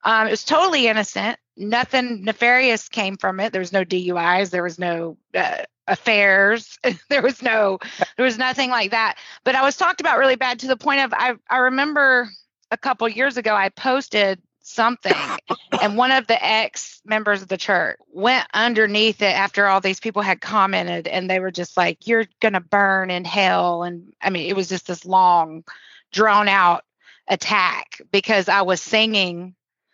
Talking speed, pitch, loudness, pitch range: 180 wpm, 210 Hz, -19 LUFS, 190-245 Hz